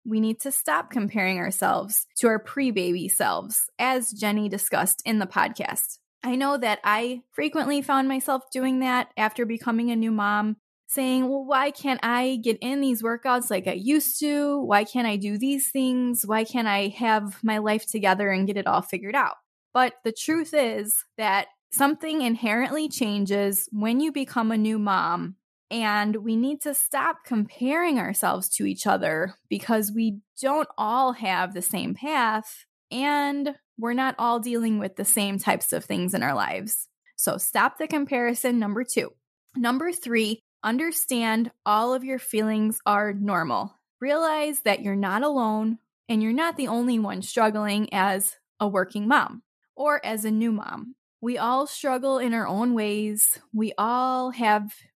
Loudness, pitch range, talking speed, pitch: -24 LUFS, 210-265 Hz, 170 wpm, 230 Hz